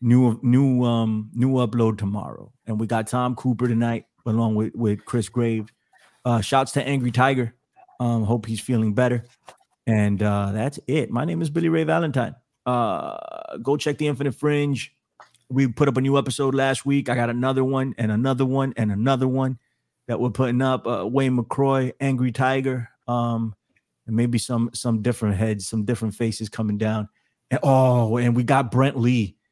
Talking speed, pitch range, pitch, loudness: 180 wpm, 115-135 Hz, 125 Hz, -23 LUFS